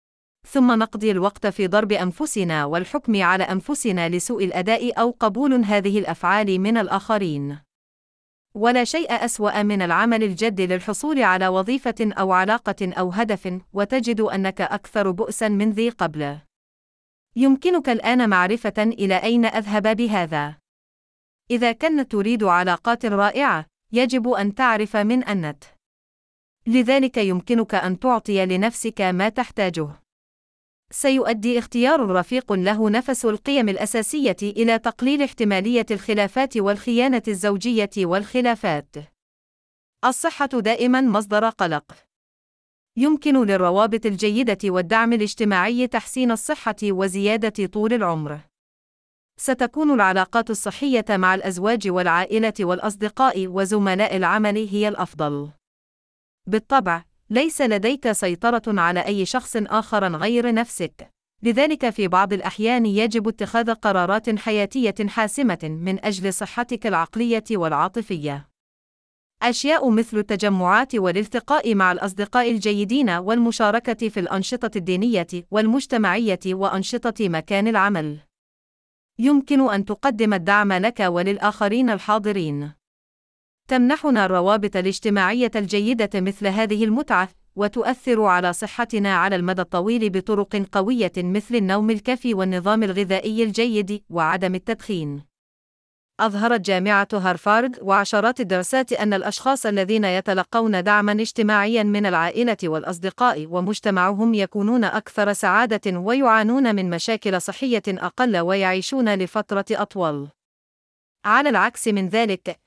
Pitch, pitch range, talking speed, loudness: 210 Hz, 190-230 Hz, 105 wpm, -21 LUFS